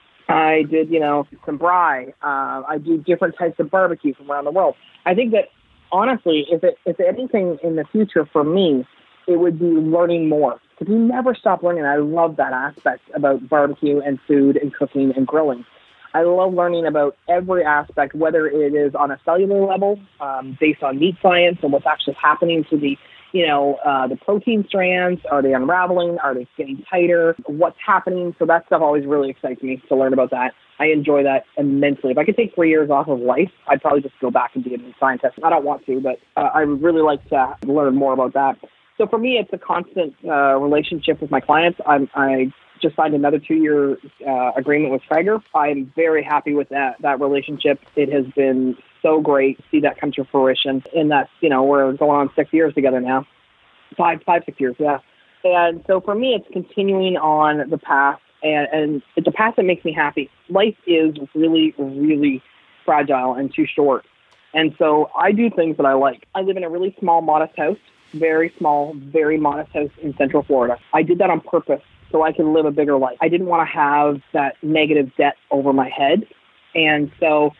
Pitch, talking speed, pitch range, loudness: 150 Hz, 210 wpm, 140-170 Hz, -18 LUFS